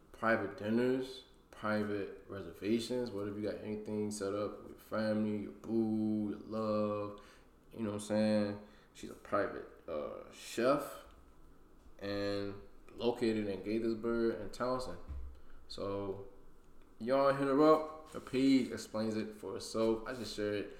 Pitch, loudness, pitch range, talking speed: 105 Hz, -36 LUFS, 100-115 Hz, 135 wpm